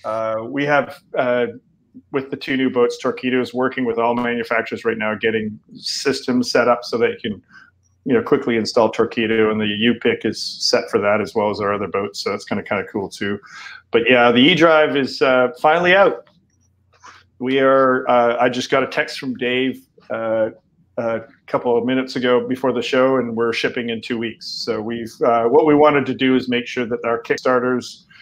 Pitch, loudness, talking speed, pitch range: 125 Hz, -18 LUFS, 215 wpm, 115-130 Hz